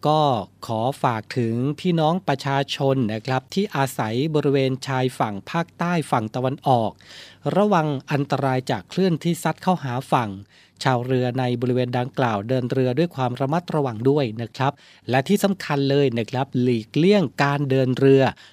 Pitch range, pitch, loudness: 125-150 Hz, 135 Hz, -22 LUFS